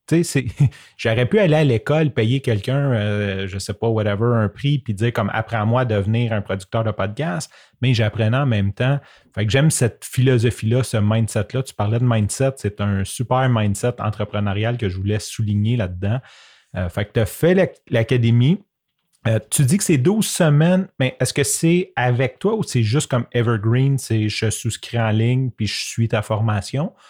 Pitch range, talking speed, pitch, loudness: 105-135 Hz, 200 wpm, 120 Hz, -20 LUFS